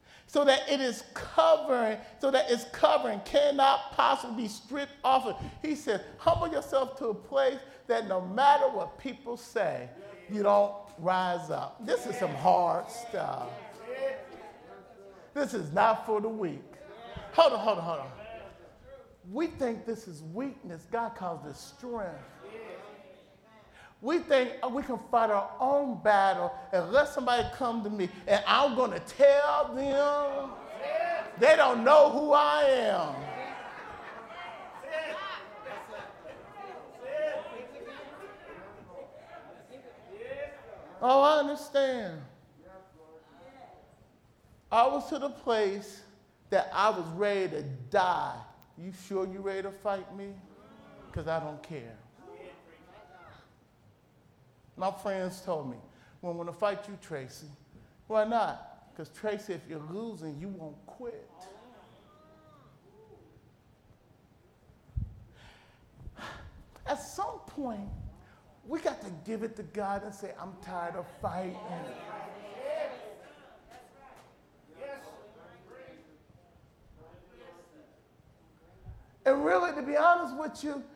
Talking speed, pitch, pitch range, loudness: 115 wpm, 230 Hz, 190-280 Hz, -29 LUFS